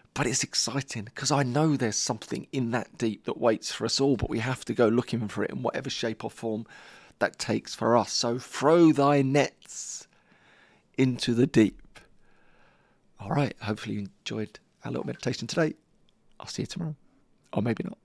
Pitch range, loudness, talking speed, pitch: 110-140 Hz, -27 LUFS, 185 wpm, 120 Hz